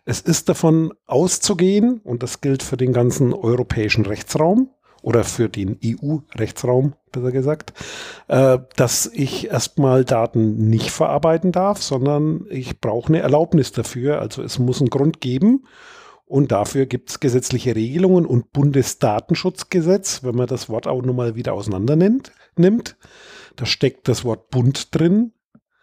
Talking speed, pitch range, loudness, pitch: 140 wpm, 120-165 Hz, -19 LUFS, 135 Hz